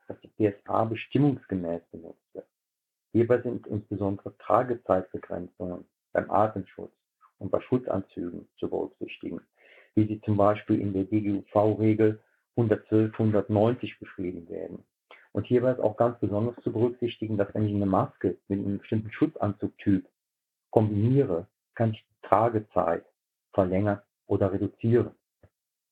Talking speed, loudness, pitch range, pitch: 120 wpm, -28 LUFS, 100-110 Hz, 105 Hz